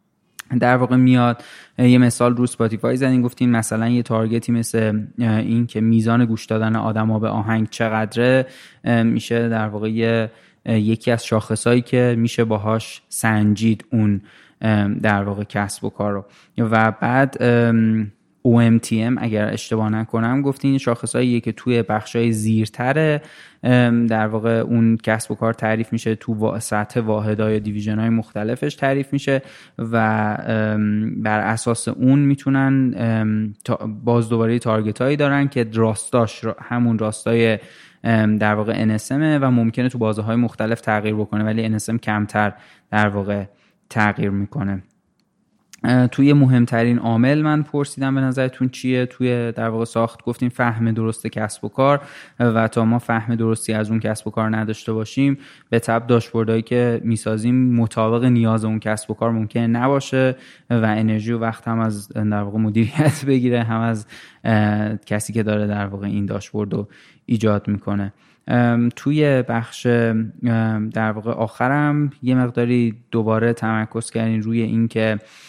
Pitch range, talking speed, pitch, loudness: 110-120 Hz, 140 wpm, 115 Hz, -19 LUFS